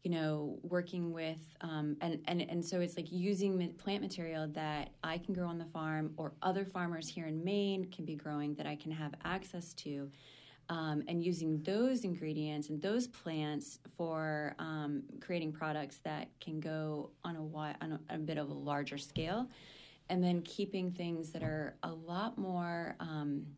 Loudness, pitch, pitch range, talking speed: -39 LUFS, 160 Hz, 150-180 Hz, 180 wpm